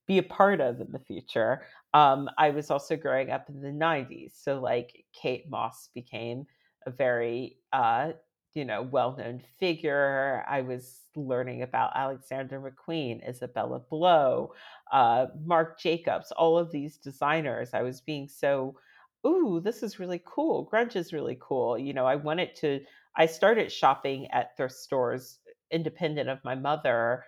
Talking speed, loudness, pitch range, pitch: 155 wpm, -28 LUFS, 130-165 Hz, 140 Hz